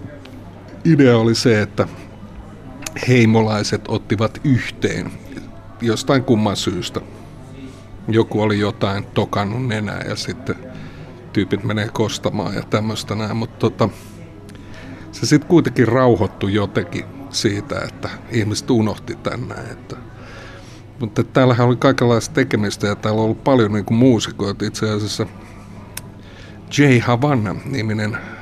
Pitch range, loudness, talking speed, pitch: 100-125 Hz, -18 LUFS, 110 wpm, 110 Hz